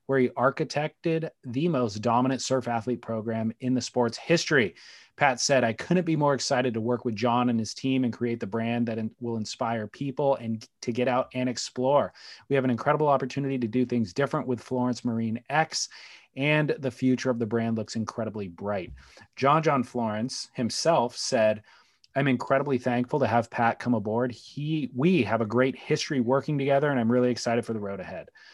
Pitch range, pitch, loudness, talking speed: 115-135 Hz, 125 Hz, -27 LUFS, 195 wpm